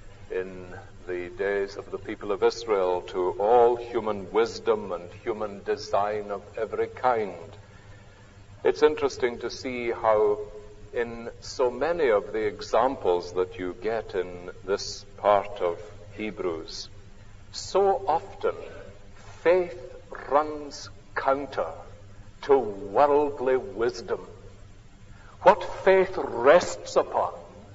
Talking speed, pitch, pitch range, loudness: 105 wpm, 105 Hz, 100-160 Hz, -26 LUFS